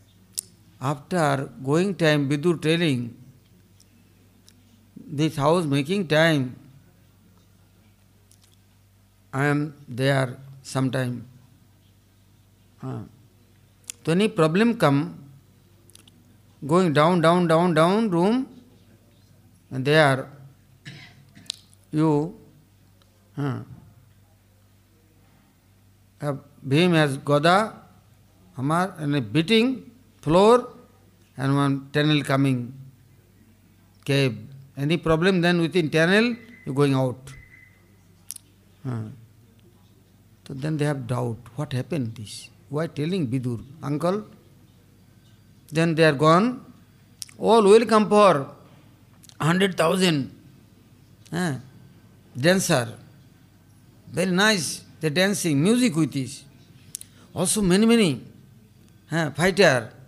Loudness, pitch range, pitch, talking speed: -22 LUFS, 105-155 Hz, 130 Hz, 80 wpm